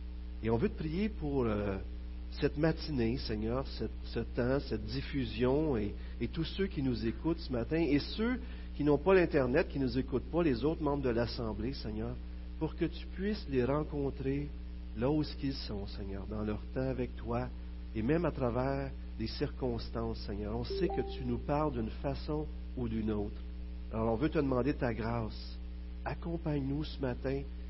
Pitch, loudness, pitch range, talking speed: 125 Hz, -35 LUFS, 100-145 Hz, 185 wpm